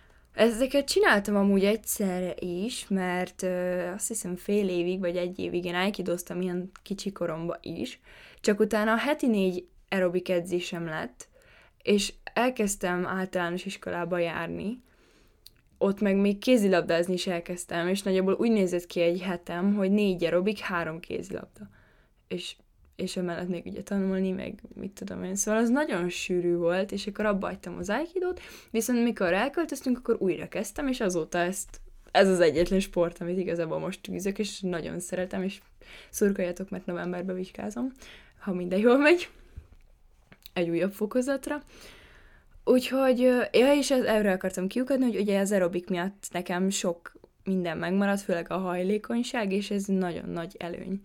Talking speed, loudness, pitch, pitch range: 150 wpm, -28 LUFS, 190 Hz, 175-215 Hz